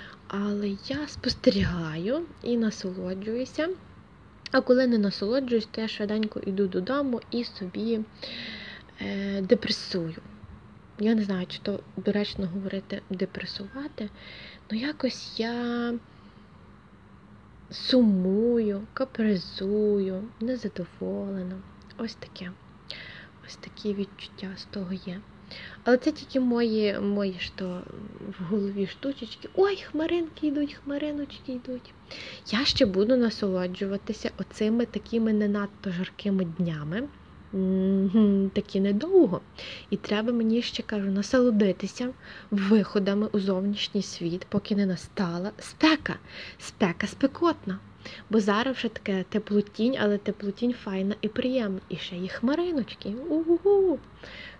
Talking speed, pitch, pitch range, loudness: 110 wpm, 210 Hz, 195-245 Hz, -28 LUFS